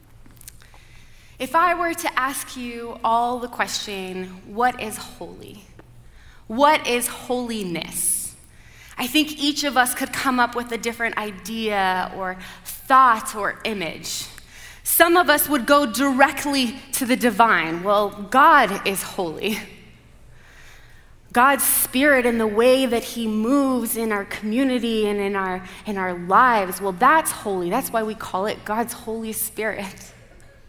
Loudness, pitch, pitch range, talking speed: -20 LUFS, 235 Hz, 205-265 Hz, 140 wpm